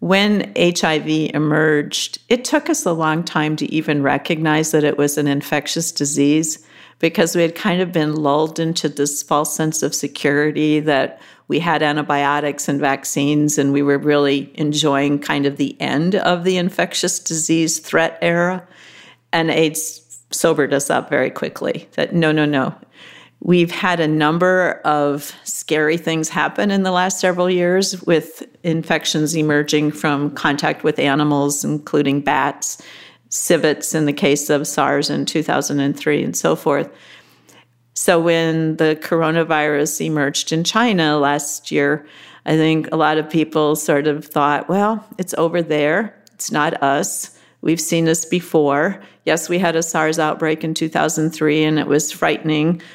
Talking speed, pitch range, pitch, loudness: 155 wpm, 145-165 Hz, 155 Hz, -17 LUFS